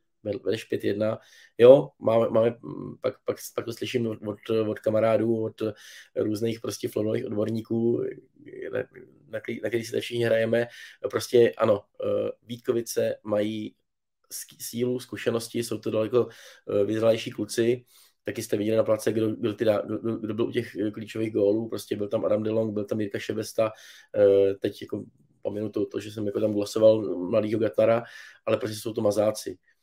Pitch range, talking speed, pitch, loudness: 110-120 Hz, 155 wpm, 110 Hz, -26 LUFS